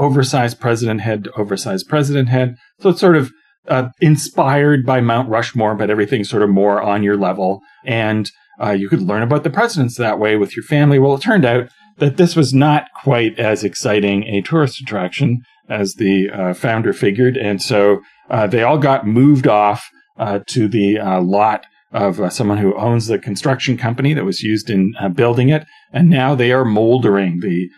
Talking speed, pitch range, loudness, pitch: 195 wpm, 105-140 Hz, -15 LUFS, 120 Hz